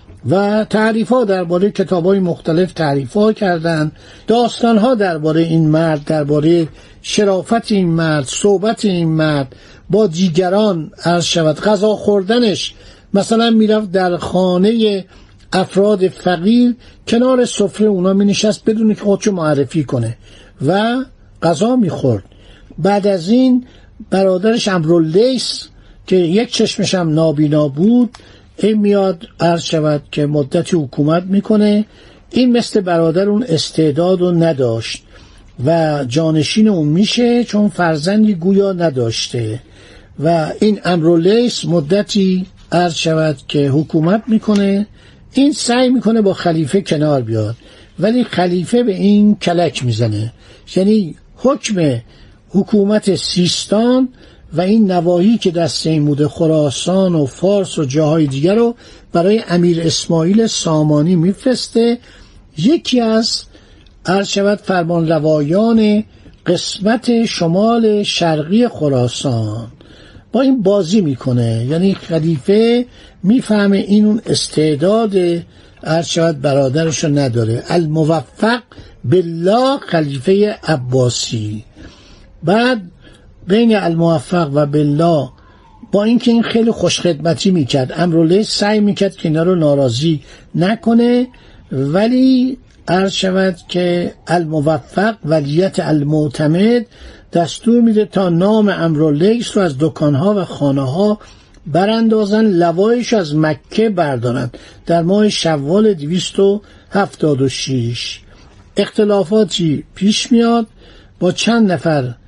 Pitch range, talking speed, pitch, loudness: 155-210 Hz, 110 wpm, 180 Hz, -14 LUFS